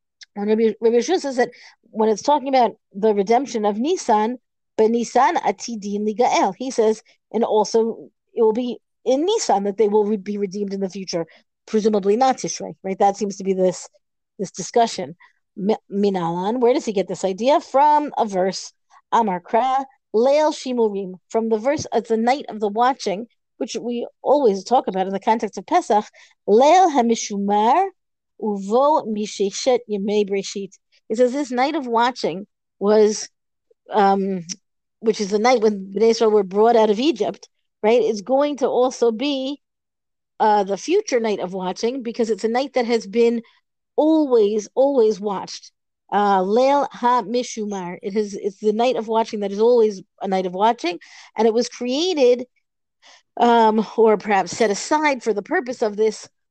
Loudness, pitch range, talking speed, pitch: -20 LUFS, 205-250 Hz, 160 wpm, 225 Hz